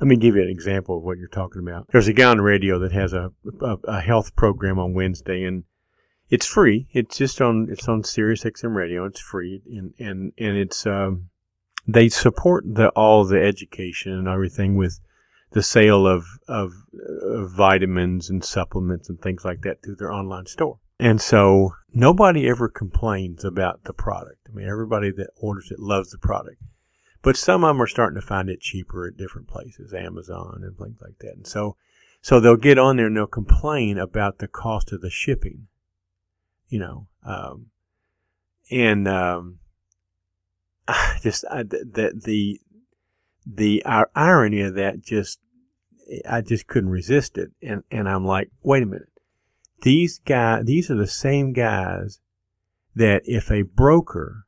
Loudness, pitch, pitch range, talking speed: -20 LUFS, 100 Hz, 95-115 Hz, 175 wpm